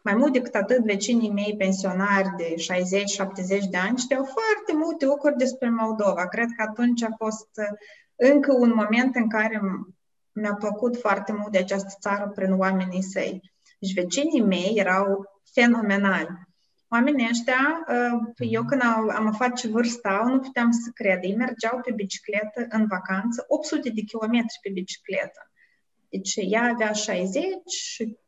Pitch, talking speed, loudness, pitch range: 220 Hz, 150 wpm, -24 LUFS, 195-245 Hz